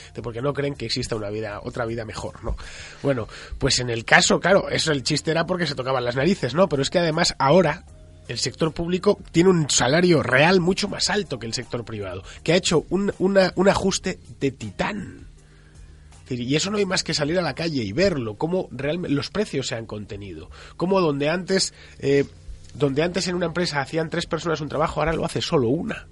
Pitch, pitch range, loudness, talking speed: 145 Hz, 115-175 Hz, -22 LUFS, 220 wpm